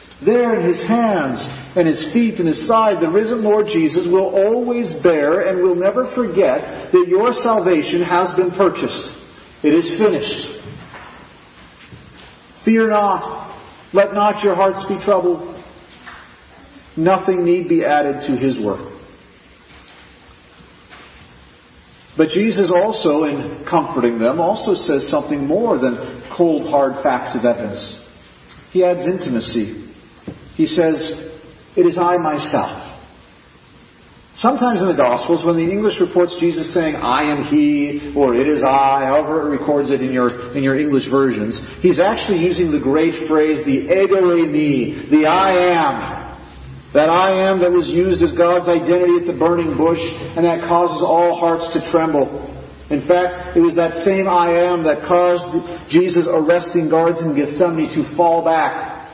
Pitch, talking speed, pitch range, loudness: 170 Hz, 150 wpm, 150-185 Hz, -16 LUFS